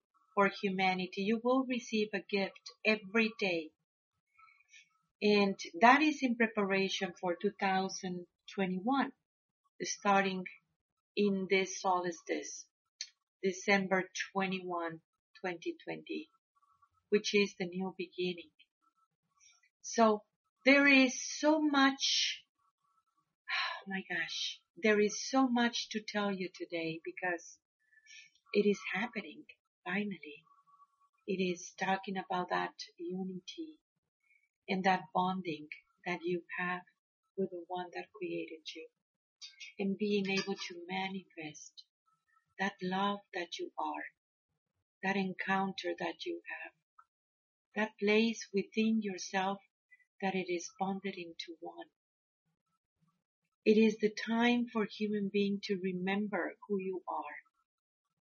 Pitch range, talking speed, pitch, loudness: 185-240 Hz, 105 wpm, 195 Hz, -34 LUFS